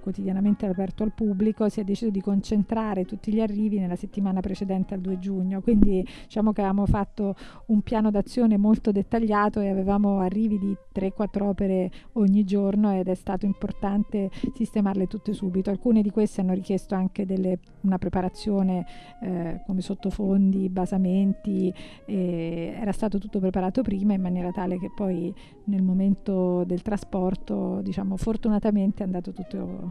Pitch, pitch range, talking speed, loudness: 195 Hz, 185-210 Hz, 155 wpm, -26 LUFS